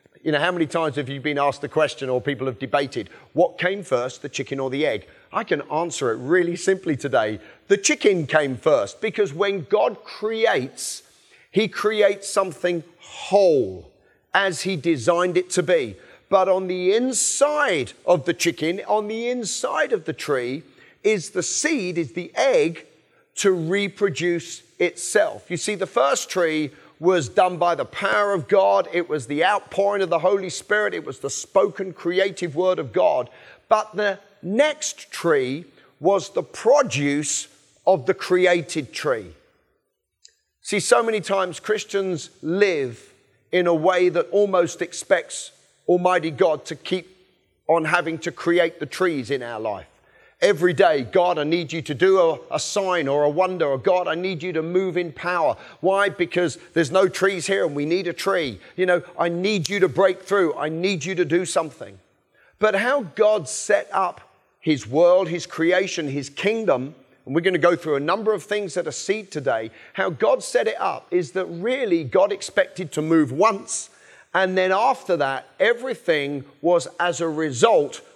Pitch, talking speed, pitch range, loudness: 180 Hz, 175 wpm, 160-195 Hz, -22 LUFS